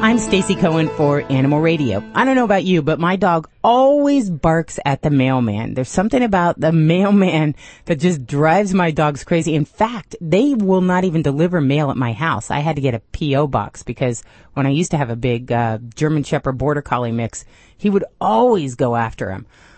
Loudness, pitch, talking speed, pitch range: -17 LUFS, 155 Hz, 205 wpm, 135-185 Hz